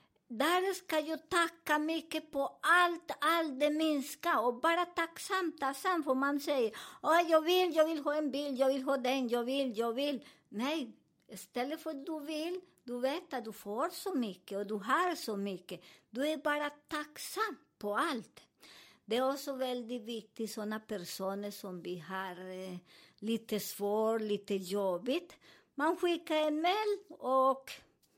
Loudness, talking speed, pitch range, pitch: -34 LUFS, 165 wpm, 220-320 Hz, 275 Hz